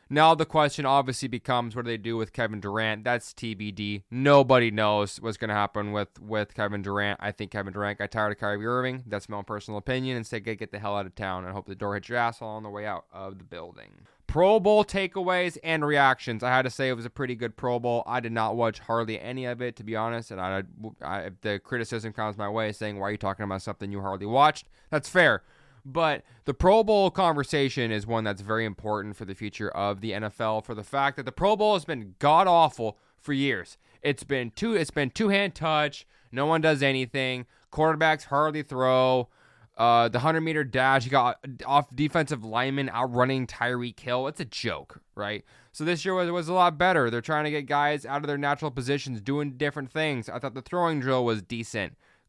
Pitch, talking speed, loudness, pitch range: 120 Hz, 225 wpm, -27 LUFS, 105-145 Hz